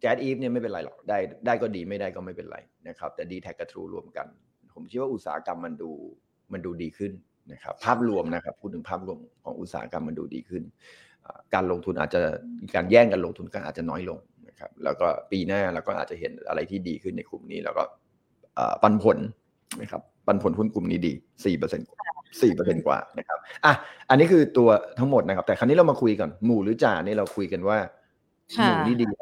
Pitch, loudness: 110 Hz, -25 LUFS